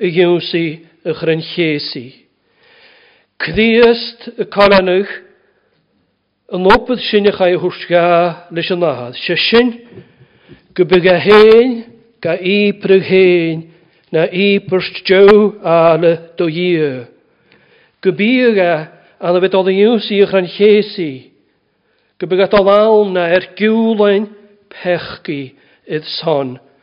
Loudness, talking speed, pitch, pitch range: -12 LUFS, 110 wpm, 185 Hz, 170-210 Hz